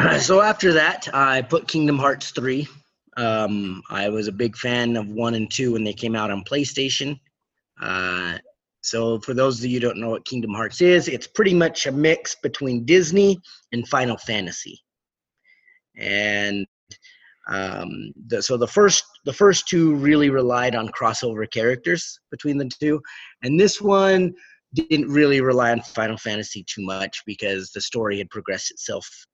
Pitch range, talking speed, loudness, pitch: 110-155 Hz, 165 wpm, -21 LUFS, 125 Hz